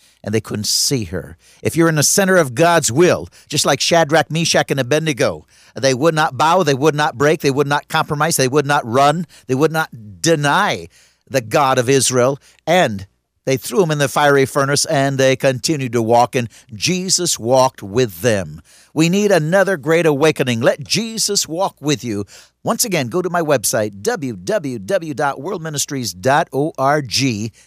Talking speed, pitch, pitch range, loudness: 170 wpm, 145 Hz, 125-165 Hz, -16 LUFS